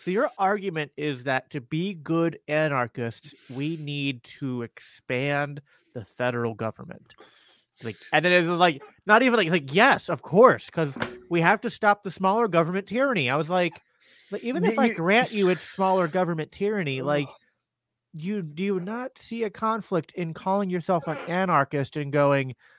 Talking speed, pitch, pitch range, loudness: 175 wpm, 170 Hz, 145-195 Hz, -25 LUFS